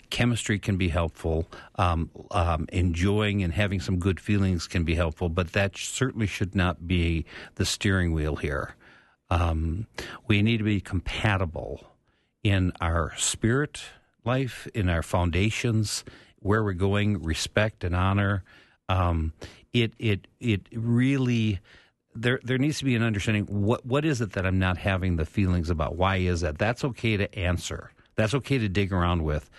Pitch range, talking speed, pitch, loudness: 90-110 Hz, 165 wpm, 100 Hz, -27 LUFS